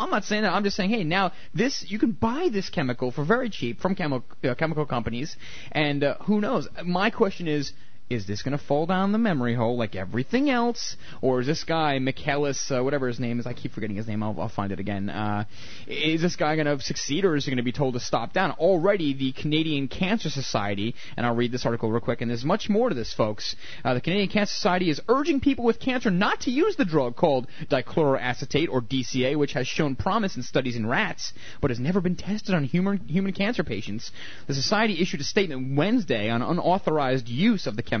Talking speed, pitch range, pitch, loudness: 230 wpm, 125-195 Hz, 145 Hz, -26 LUFS